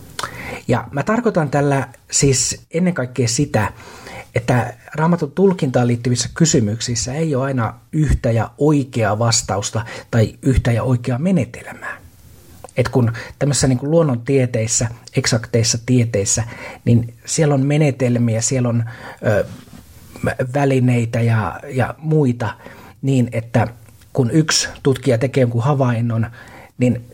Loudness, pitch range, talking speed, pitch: -18 LUFS, 115-140 Hz, 115 wpm, 125 Hz